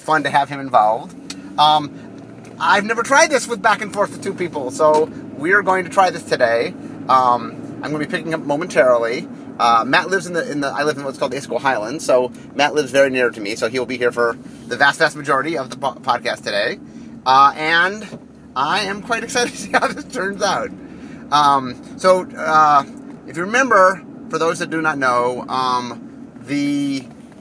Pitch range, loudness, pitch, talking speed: 140-230 Hz, -17 LUFS, 170 Hz, 210 wpm